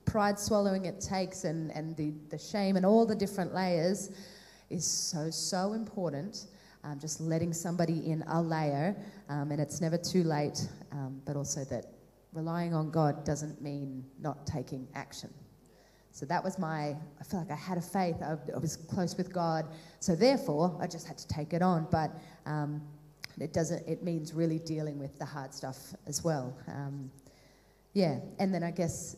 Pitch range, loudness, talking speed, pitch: 150-180 Hz, -34 LUFS, 185 wpm, 160 Hz